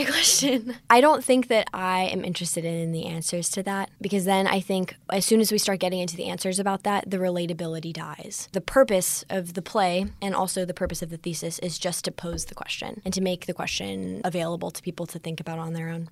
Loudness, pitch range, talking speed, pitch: -25 LUFS, 170-195 Hz, 235 wpm, 180 Hz